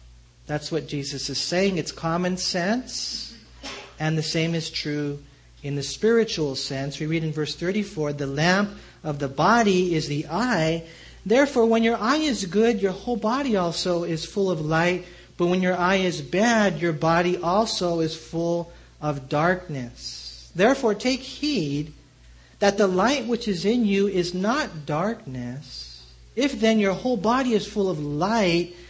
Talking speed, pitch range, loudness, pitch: 165 wpm, 150-210 Hz, -24 LUFS, 175 Hz